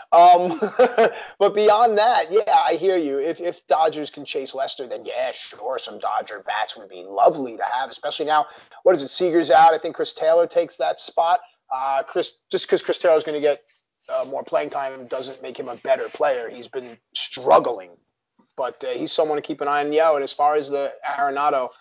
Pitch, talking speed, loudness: 170 Hz, 210 wpm, -21 LUFS